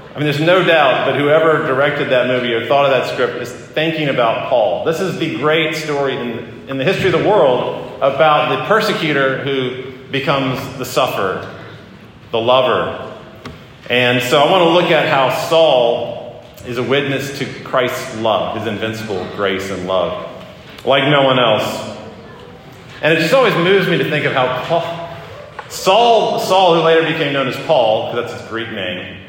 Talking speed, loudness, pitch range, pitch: 180 wpm, -15 LUFS, 125-160 Hz, 135 Hz